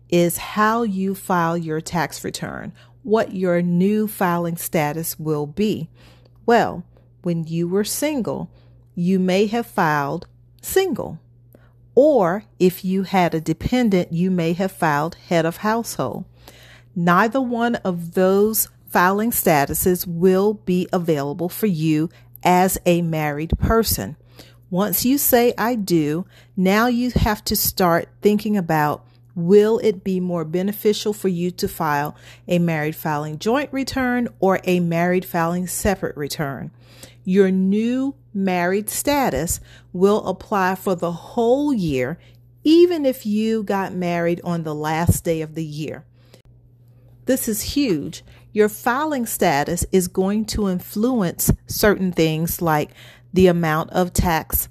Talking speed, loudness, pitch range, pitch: 135 wpm, -20 LUFS, 155-210 Hz, 180 Hz